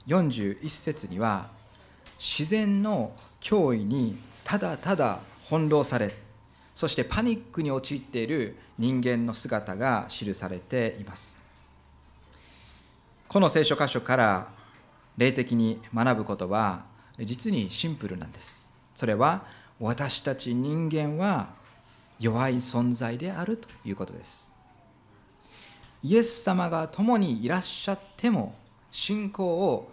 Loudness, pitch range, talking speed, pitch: -28 LUFS, 105-160 Hz, 220 characters per minute, 125 Hz